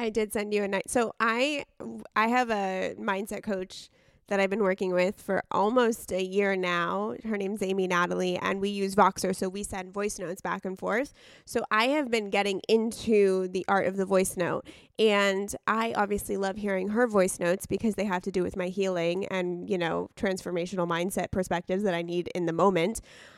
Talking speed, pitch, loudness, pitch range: 205 wpm, 195 Hz, -28 LUFS, 185-210 Hz